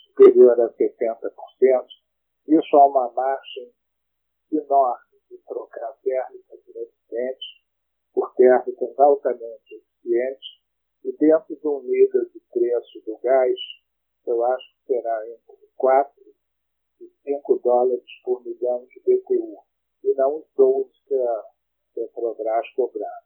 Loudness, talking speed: -21 LUFS, 120 wpm